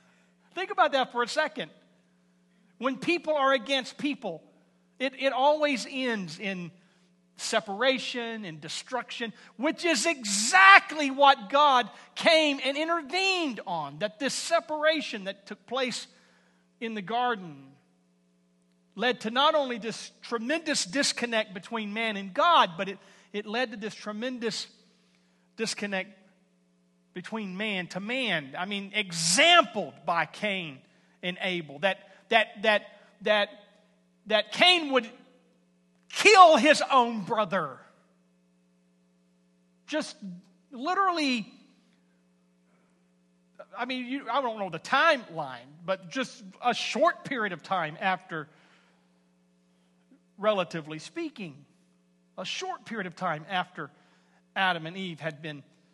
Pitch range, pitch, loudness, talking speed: 155-255 Hz, 205 Hz, -26 LUFS, 115 wpm